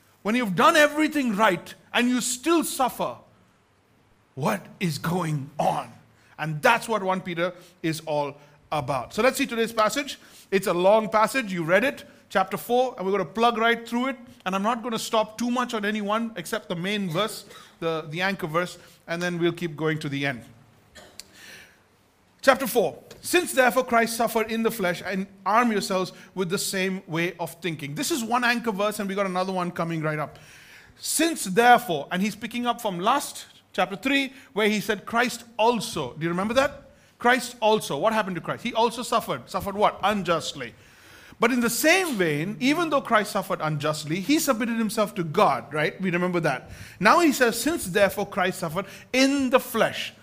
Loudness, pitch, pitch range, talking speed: -24 LUFS, 205 Hz, 175-235 Hz, 190 wpm